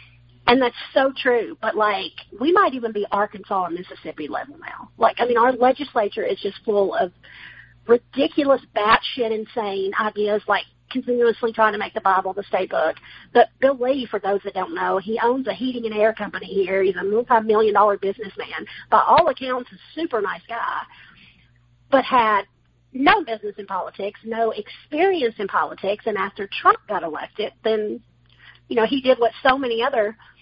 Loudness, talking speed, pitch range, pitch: -21 LUFS, 180 wpm, 200-255 Hz, 220 Hz